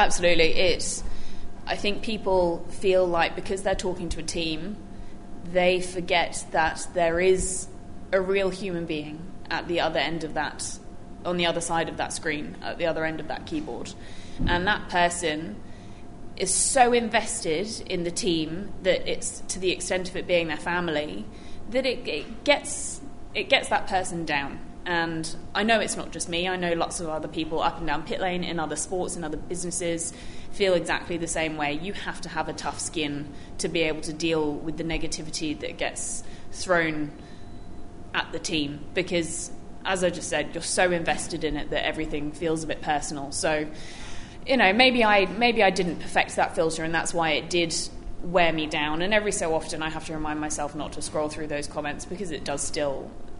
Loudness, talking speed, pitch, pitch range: -26 LUFS, 195 wpm, 165 Hz, 155-180 Hz